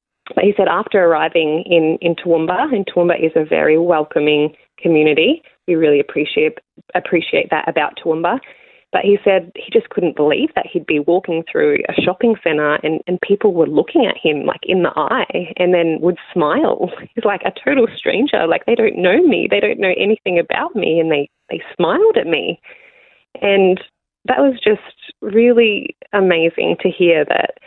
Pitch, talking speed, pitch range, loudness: 180 Hz, 180 wpm, 165-220 Hz, -15 LUFS